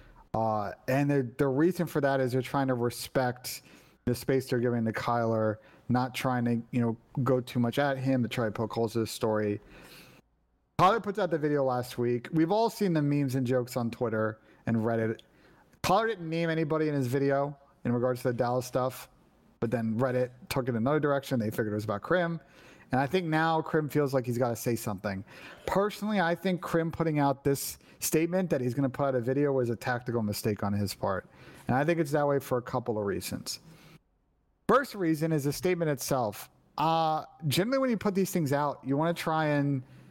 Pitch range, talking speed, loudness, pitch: 120-160 Hz, 215 wpm, -30 LUFS, 135 Hz